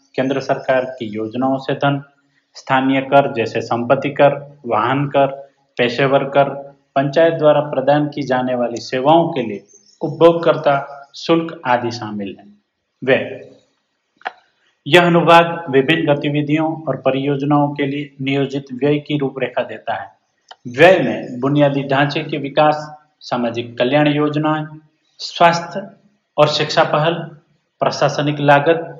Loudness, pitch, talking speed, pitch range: -16 LUFS, 140 Hz, 120 wpm, 135-155 Hz